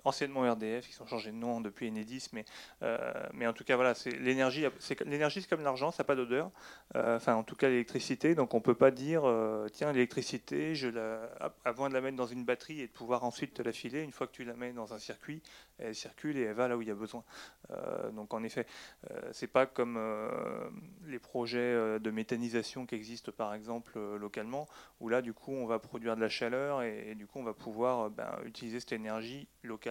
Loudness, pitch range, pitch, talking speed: -35 LUFS, 115-130 Hz, 120 Hz, 245 wpm